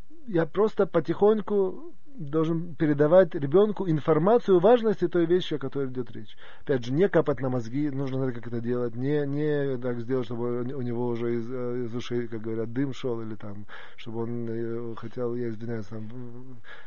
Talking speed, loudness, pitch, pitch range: 175 wpm, -27 LUFS, 130 Hz, 120-165 Hz